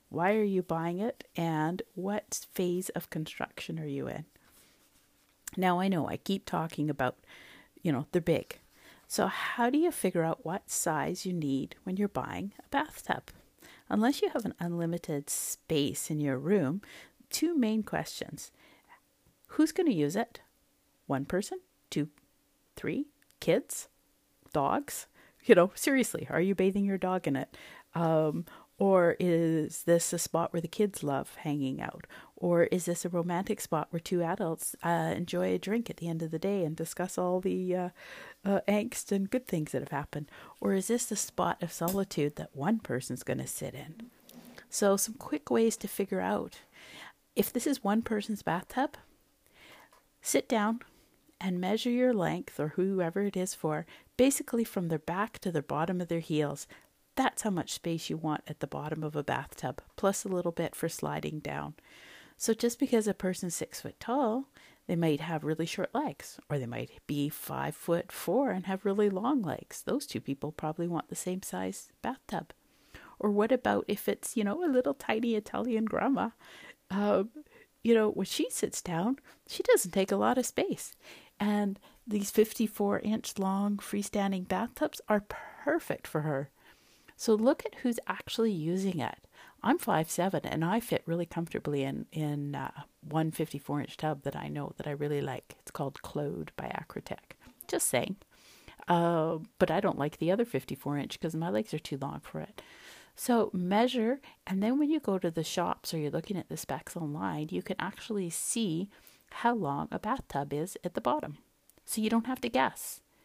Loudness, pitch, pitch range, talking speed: -32 LUFS, 185 Hz, 160-220 Hz, 180 wpm